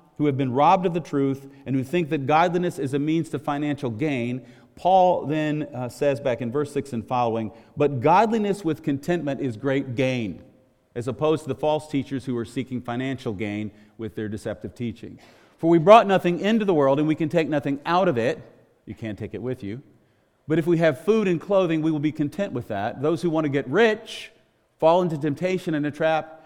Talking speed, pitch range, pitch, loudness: 220 wpm, 125-160 Hz, 145 Hz, -23 LUFS